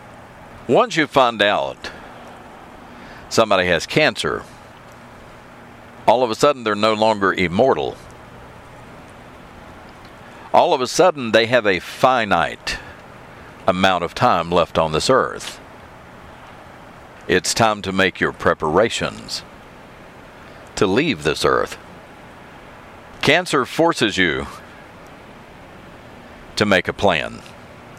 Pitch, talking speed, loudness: 105 Hz, 100 wpm, -18 LUFS